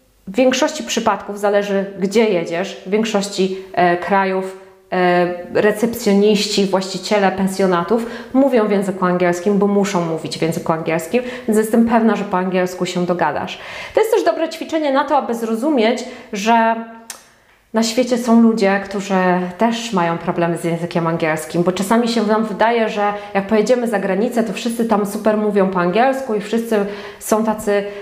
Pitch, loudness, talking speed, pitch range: 205 Hz, -17 LUFS, 160 wpm, 185-230 Hz